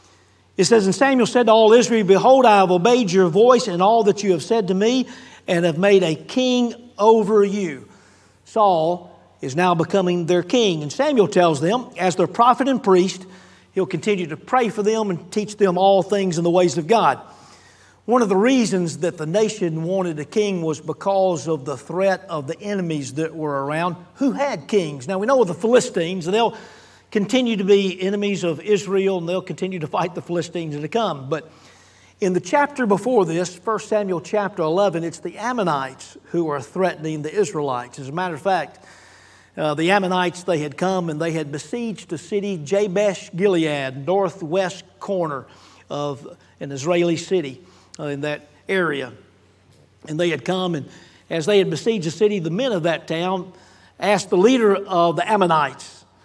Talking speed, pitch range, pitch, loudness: 185 wpm, 165-205 Hz, 185 Hz, -20 LUFS